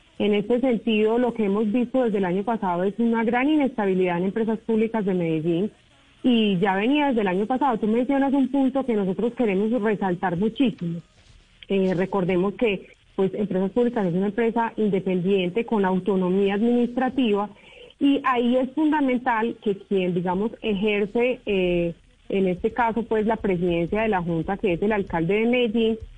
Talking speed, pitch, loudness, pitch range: 165 wpm, 215 Hz, -23 LUFS, 190-235 Hz